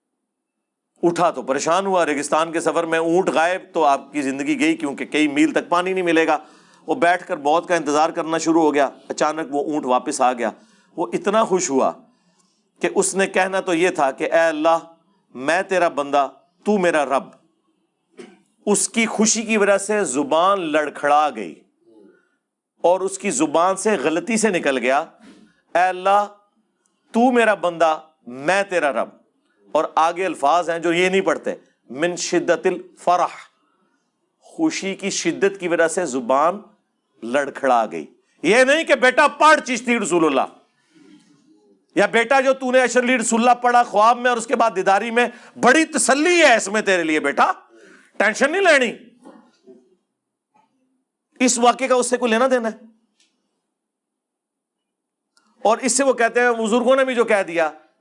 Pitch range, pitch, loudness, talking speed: 165-245 Hz, 195 Hz, -19 LUFS, 170 wpm